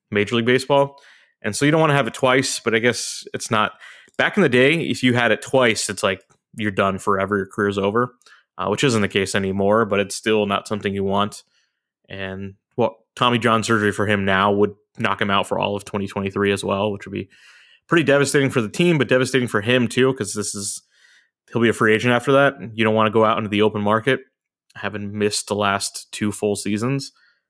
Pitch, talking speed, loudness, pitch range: 110 Hz, 230 wpm, -20 LUFS, 100-125 Hz